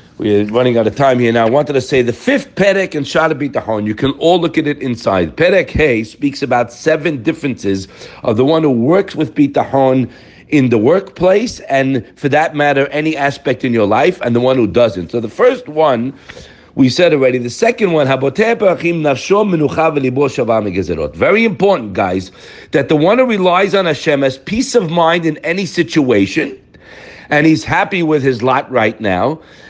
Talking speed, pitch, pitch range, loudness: 180 wpm, 145 Hz, 125-170 Hz, -13 LUFS